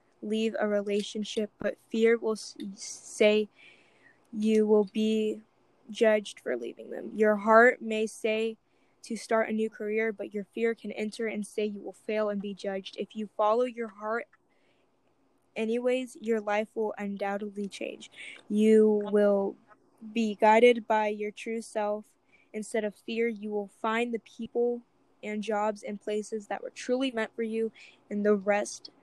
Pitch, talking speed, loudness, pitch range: 215 Hz, 155 wpm, -29 LUFS, 210-225 Hz